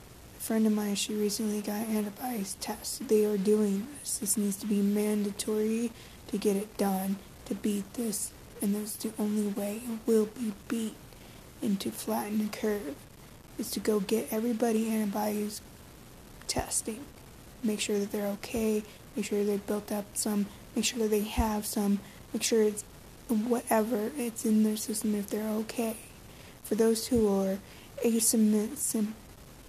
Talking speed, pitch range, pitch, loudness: 160 wpm, 210-225 Hz, 215 Hz, -31 LUFS